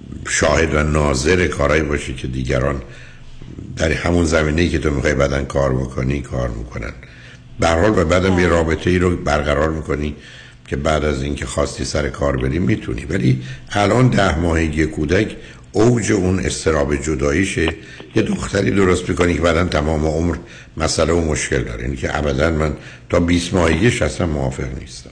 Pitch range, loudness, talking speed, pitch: 70-85 Hz, -18 LUFS, 160 wpm, 75 Hz